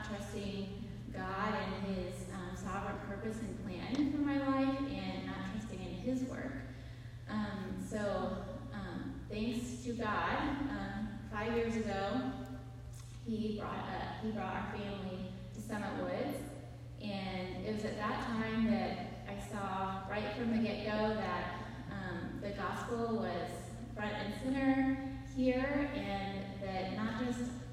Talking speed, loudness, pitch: 140 wpm, -39 LUFS, 125 Hz